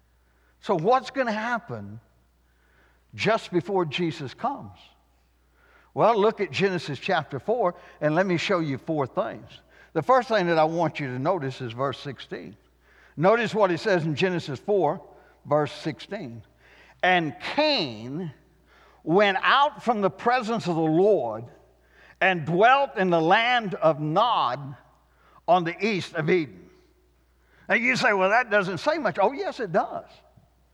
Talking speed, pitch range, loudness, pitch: 150 wpm, 135-205 Hz, -24 LUFS, 170 Hz